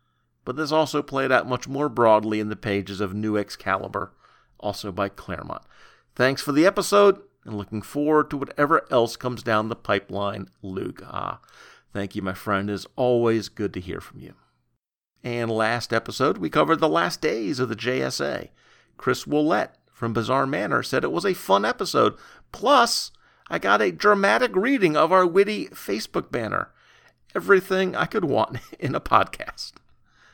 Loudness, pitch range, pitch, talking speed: -23 LUFS, 105-150 Hz, 120 Hz, 165 wpm